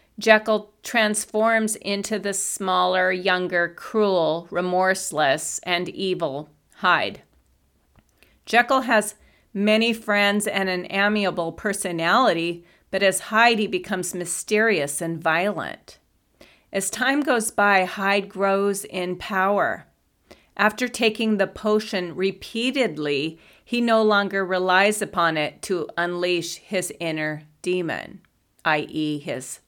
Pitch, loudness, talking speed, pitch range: 195 Hz, -22 LUFS, 105 wpm, 175-215 Hz